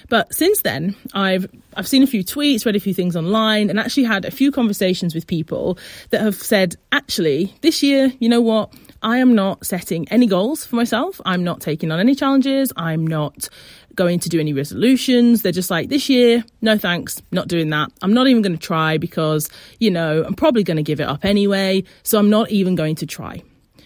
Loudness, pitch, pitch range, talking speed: -18 LUFS, 200 Hz, 170-235 Hz, 215 wpm